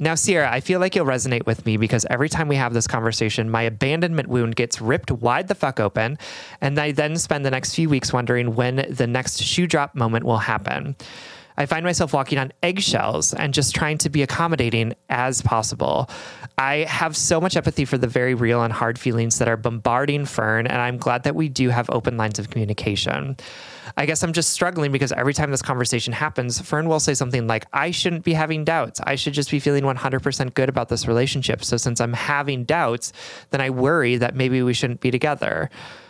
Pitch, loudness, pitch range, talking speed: 130 Hz, -21 LUFS, 120-150 Hz, 215 wpm